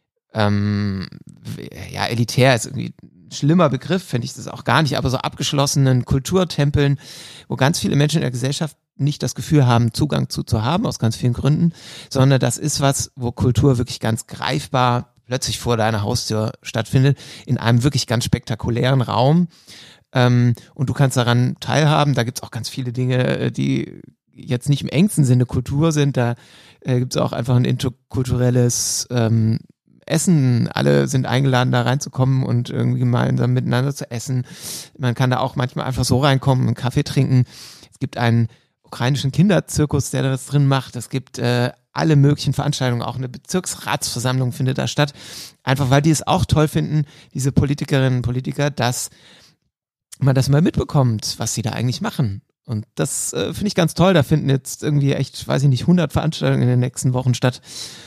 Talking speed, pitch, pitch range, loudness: 180 wpm, 130 Hz, 120-145 Hz, -19 LUFS